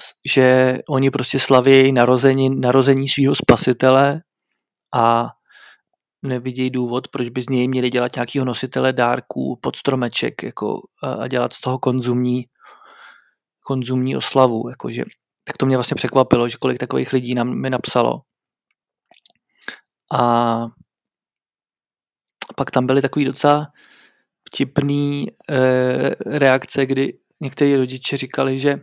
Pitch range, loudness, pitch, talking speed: 125-135 Hz, -18 LUFS, 130 Hz, 120 wpm